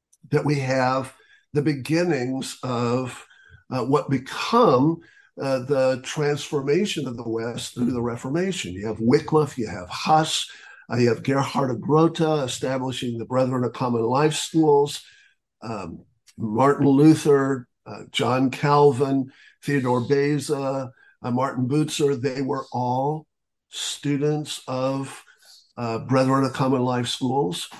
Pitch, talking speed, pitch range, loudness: 135 Hz, 125 wpm, 125-145 Hz, -23 LUFS